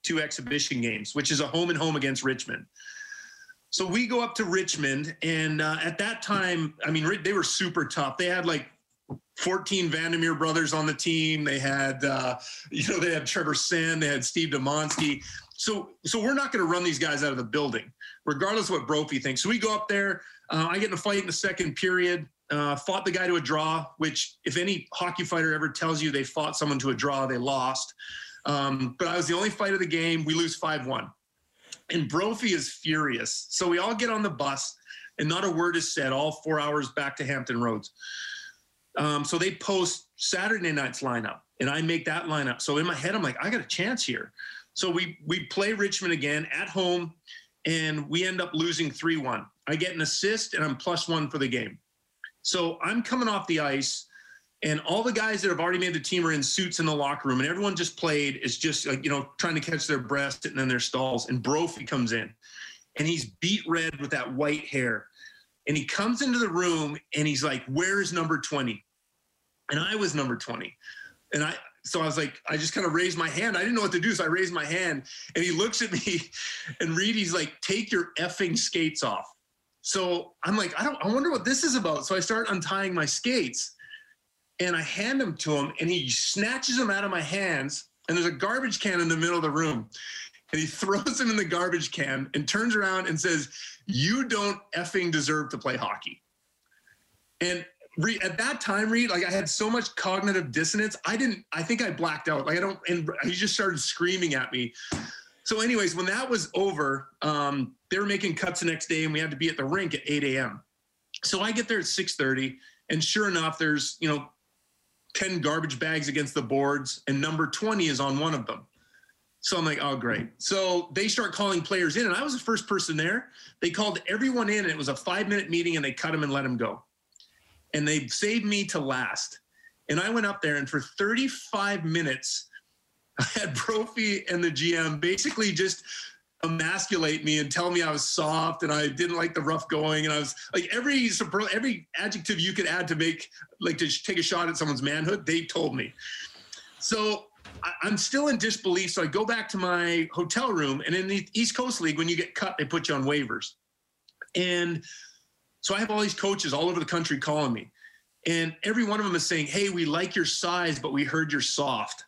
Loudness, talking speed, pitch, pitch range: -28 LUFS, 220 wpm, 170 Hz, 150-195 Hz